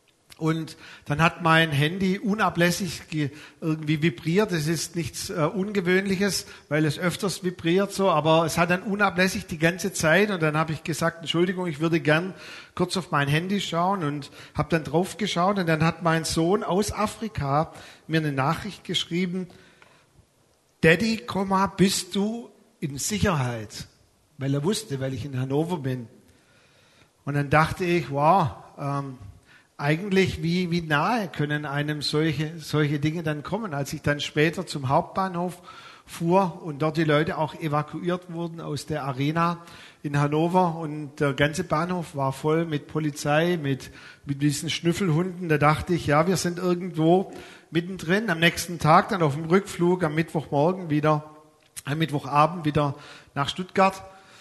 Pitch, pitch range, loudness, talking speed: 165 Hz, 150-185 Hz, -25 LUFS, 155 wpm